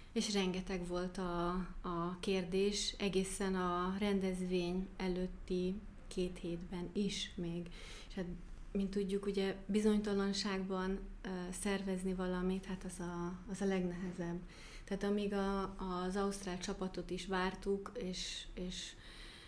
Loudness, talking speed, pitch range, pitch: -39 LUFS, 120 wpm, 180-195 Hz, 185 Hz